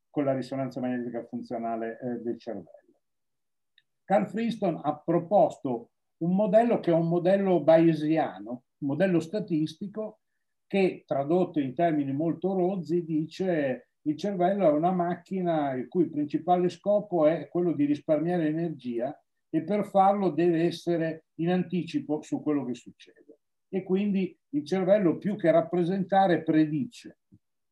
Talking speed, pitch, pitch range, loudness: 135 wpm, 170 Hz, 150-190 Hz, -27 LUFS